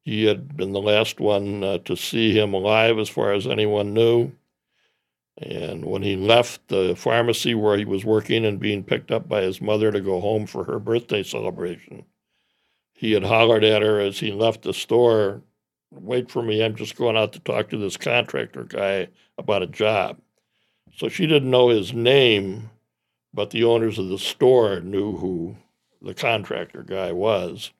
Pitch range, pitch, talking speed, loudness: 100-115 Hz, 105 Hz, 180 wpm, -21 LUFS